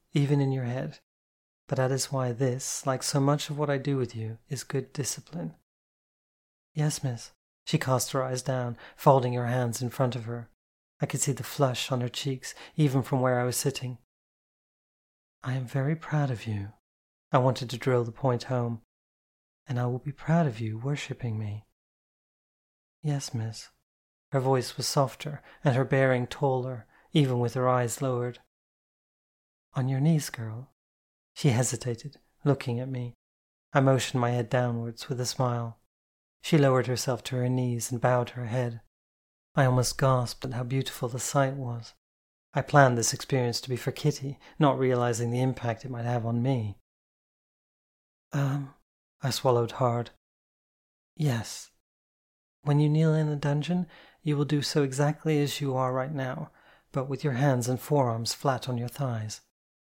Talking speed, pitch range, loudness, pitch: 170 wpm, 115-140 Hz, -28 LUFS, 125 Hz